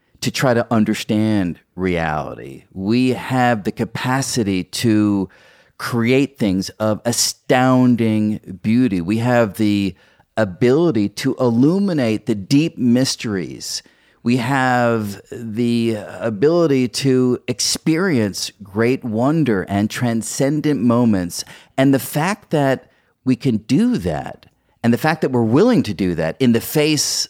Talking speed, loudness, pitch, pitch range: 120 wpm, -18 LUFS, 120 Hz, 105-130 Hz